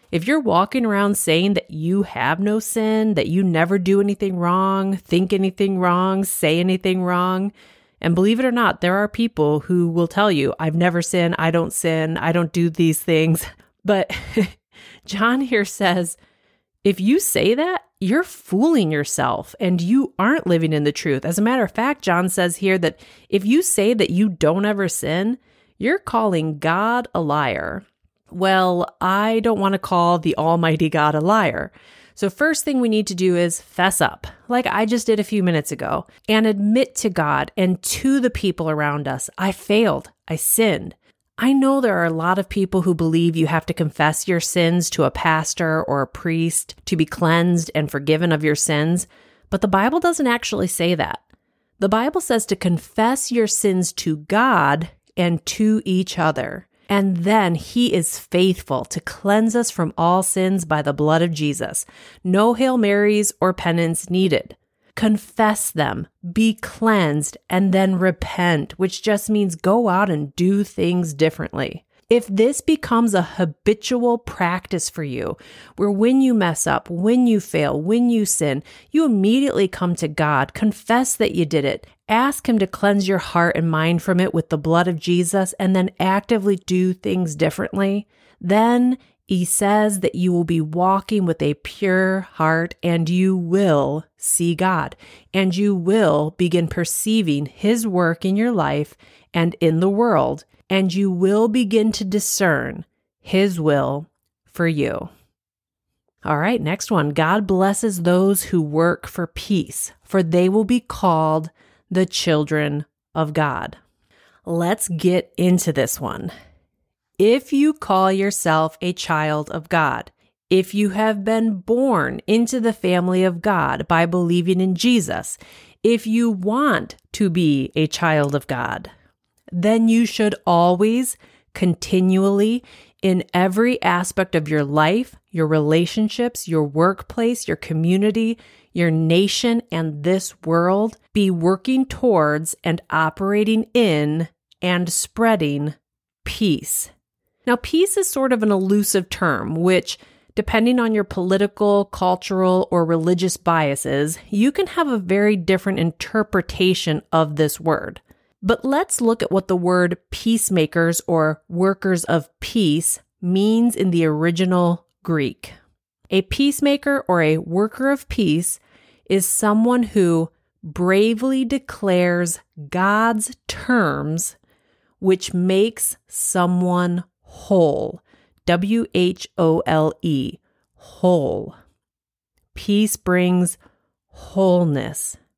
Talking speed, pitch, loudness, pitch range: 150 wpm, 185 Hz, -19 LUFS, 165-215 Hz